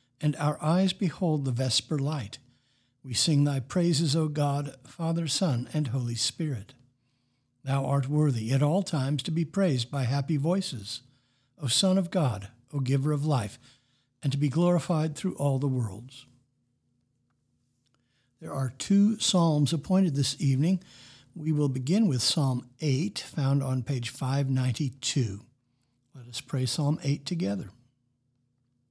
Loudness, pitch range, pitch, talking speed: -28 LUFS, 125-150 Hz, 135 Hz, 145 wpm